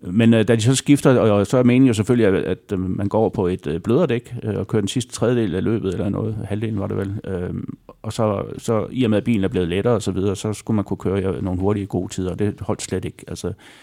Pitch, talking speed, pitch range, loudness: 105 Hz, 260 wpm, 95-115 Hz, -20 LUFS